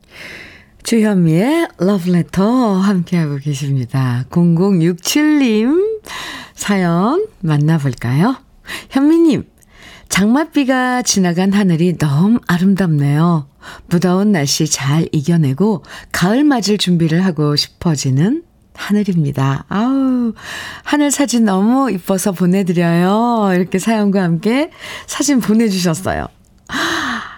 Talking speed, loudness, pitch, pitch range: 230 characters per minute, -15 LUFS, 190 Hz, 165-230 Hz